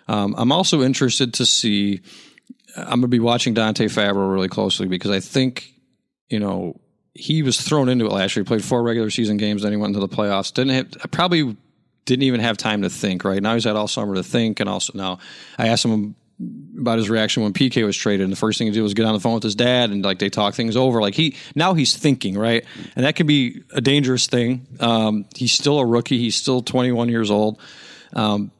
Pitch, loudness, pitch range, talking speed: 115 Hz, -19 LUFS, 105-130 Hz, 235 wpm